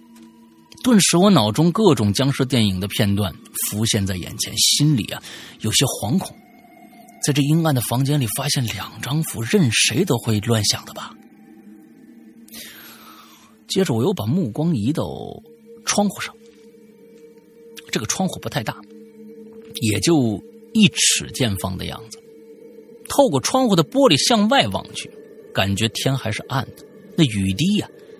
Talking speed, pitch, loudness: 210 characters per minute, 155 Hz, -19 LUFS